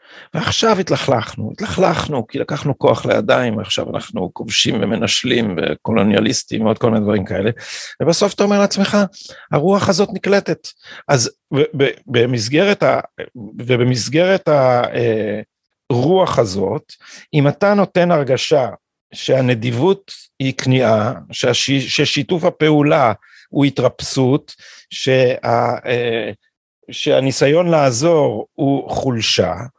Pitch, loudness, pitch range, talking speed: 140 Hz, -16 LUFS, 120-175 Hz, 100 wpm